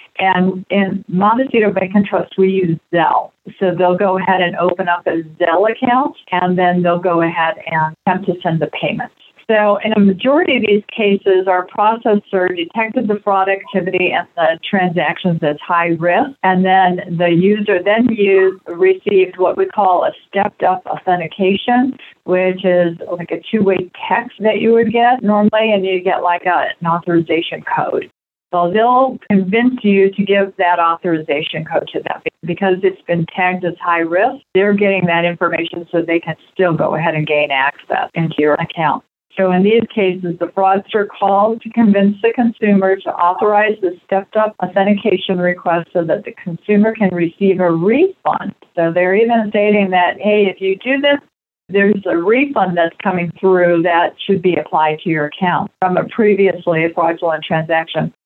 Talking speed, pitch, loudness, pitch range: 175 wpm, 190 Hz, -15 LUFS, 175-210 Hz